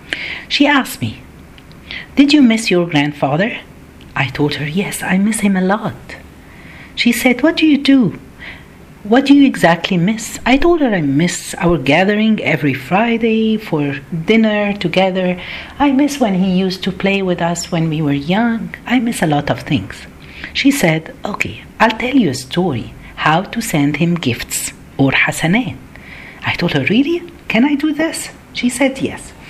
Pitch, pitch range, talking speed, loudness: 200 Hz, 170-245 Hz, 175 wpm, -15 LUFS